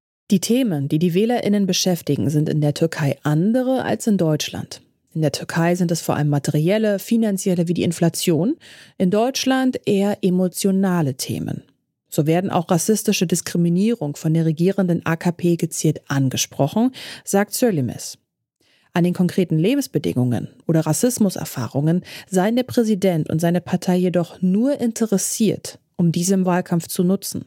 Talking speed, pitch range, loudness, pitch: 140 wpm, 160-205 Hz, -20 LUFS, 180 Hz